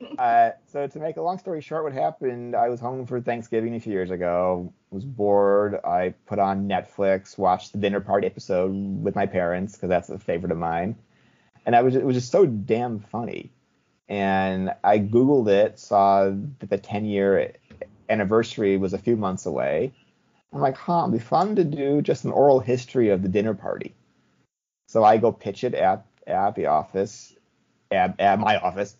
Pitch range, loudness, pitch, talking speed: 95-125 Hz, -23 LUFS, 105 Hz, 190 wpm